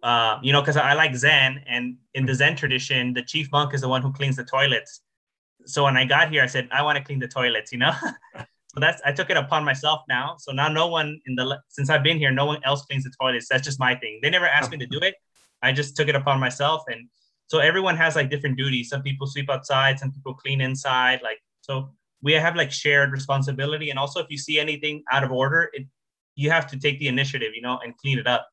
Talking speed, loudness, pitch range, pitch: 255 wpm, -22 LUFS, 130-150 Hz, 140 Hz